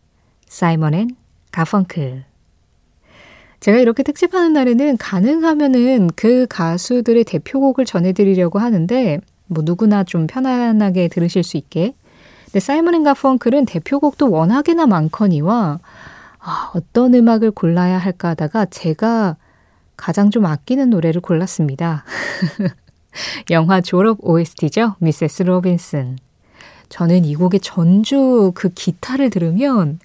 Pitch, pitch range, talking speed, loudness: 190 Hz, 165-240 Hz, 275 characters per minute, -15 LUFS